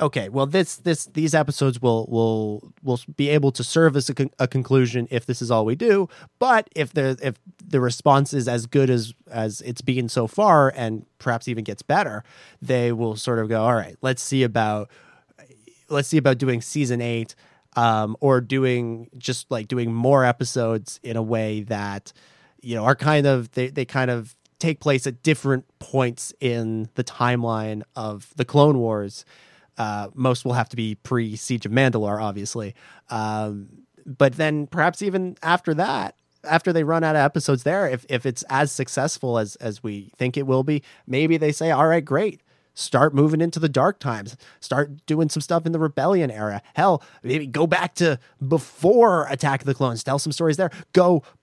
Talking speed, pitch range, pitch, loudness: 190 wpm, 115-150 Hz, 130 Hz, -22 LUFS